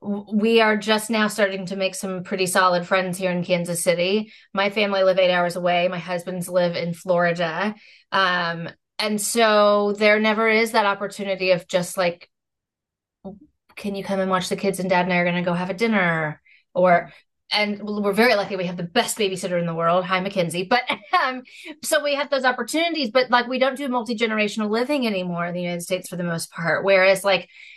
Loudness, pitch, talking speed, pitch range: -21 LUFS, 195 Hz, 205 wpm, 180-220 Hz